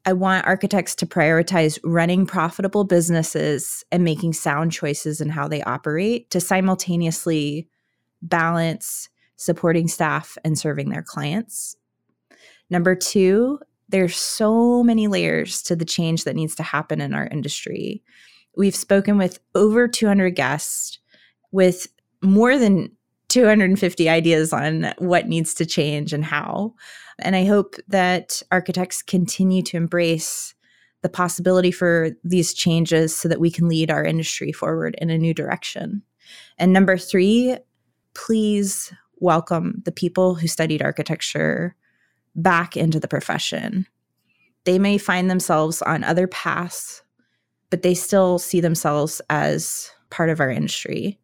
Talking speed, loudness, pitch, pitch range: 135 wpm, -20 LUFS, 175 Hz, 165-190 Hz